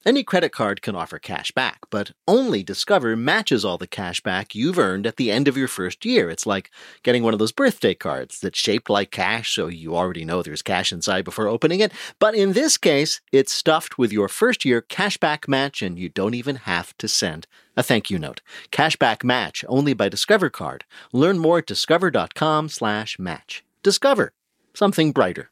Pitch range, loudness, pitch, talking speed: 100-165 Hz, -21 LUFS, 135 Hz, 200 wpm